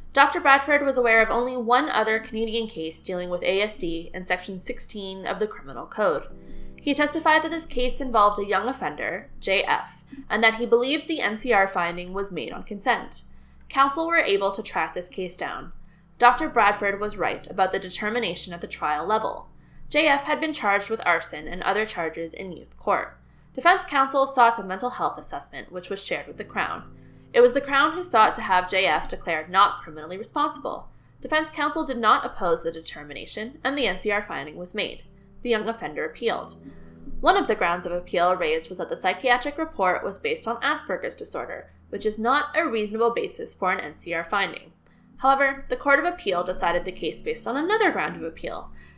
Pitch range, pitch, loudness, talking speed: 185-275 Hz, 225 Hz, -24 LUFS, 190 wpm